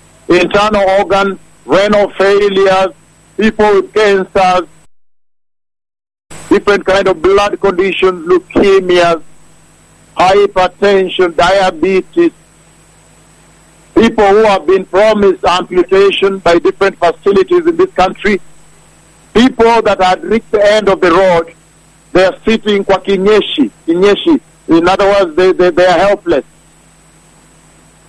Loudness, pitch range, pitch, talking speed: -10 LUFS, 185-210 Hz, 195 Hz, 105 wpm